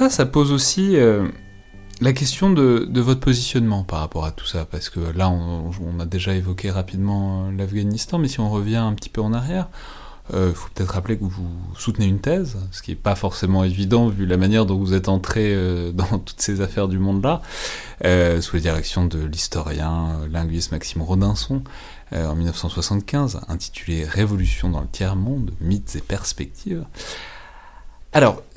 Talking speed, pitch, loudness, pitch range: 180 wpm, 95 Hz, -21 LUFS, 85-110 Hz